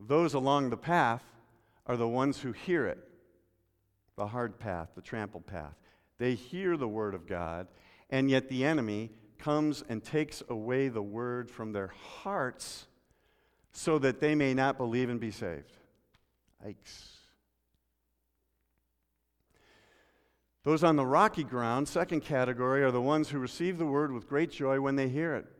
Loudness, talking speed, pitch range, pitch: -32 LUFS, 155 wpm, 100-140 Hz, 120 Hz